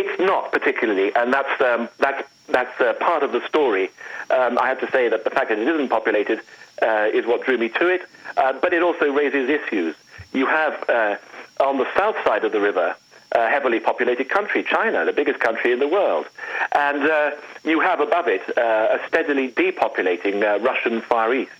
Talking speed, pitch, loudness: 205 wpm, 385 Hz, -20 LUFS